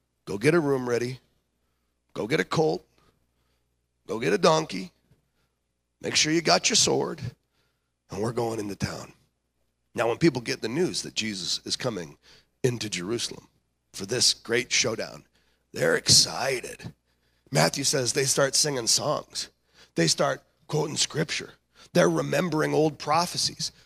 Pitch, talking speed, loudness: 110 Hz, 140 wpm, -25 LUFS